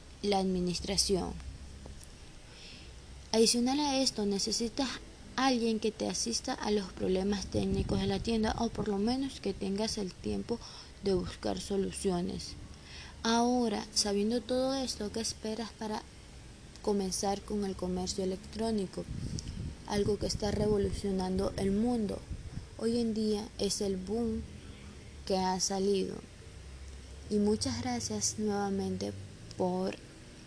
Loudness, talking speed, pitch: -33 LUFS, 120 wpm, 200 Hz